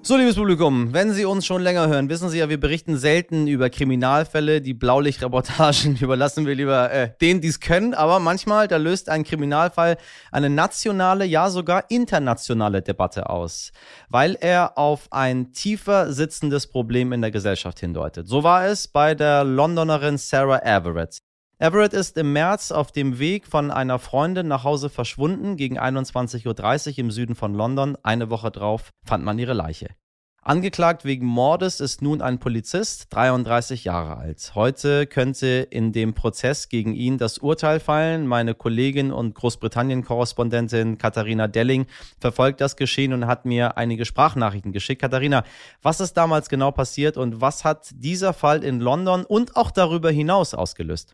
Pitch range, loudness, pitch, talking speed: 120-160 Hz, -21 LUFS, 135 Hz, 165 wpm